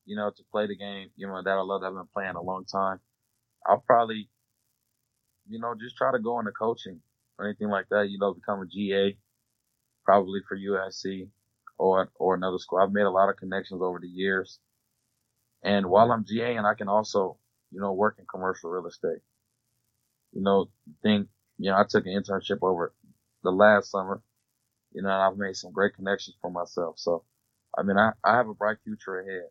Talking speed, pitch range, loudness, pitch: 205 wpm, 95-115 Hz, -27 LUFS, 100 Hz